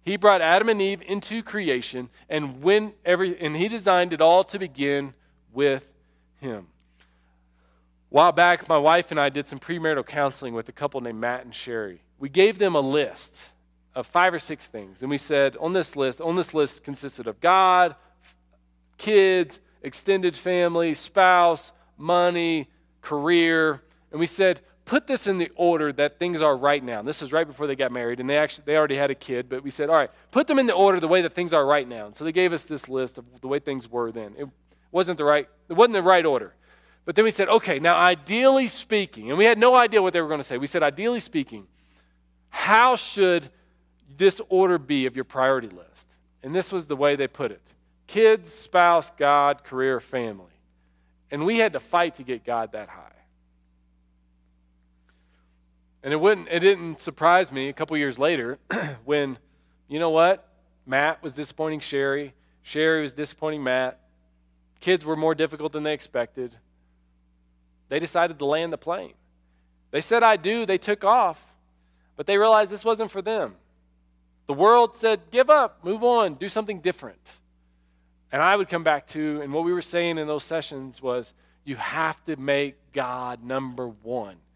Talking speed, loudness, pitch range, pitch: 190 wpm, -22 LUFS, 120-180 Hz, 150 Hz